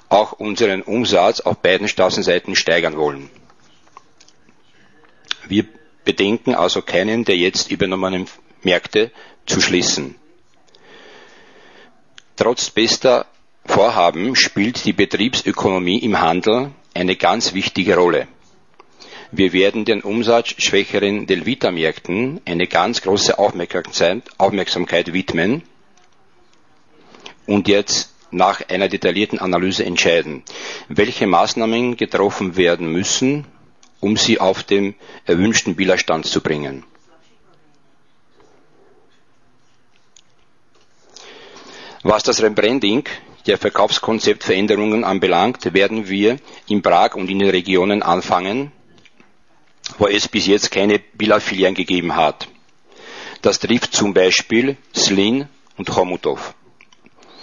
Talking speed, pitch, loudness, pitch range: 95 wpm, 100 Hz, -17 LUFS, 95-115 Hz